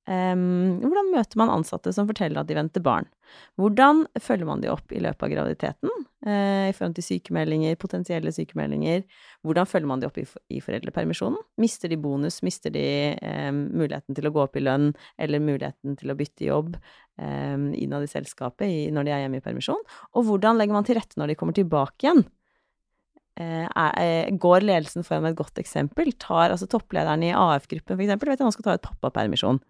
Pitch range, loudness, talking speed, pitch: 145-200 Hz, -25 LUFS, 200 wpm, 170 Hz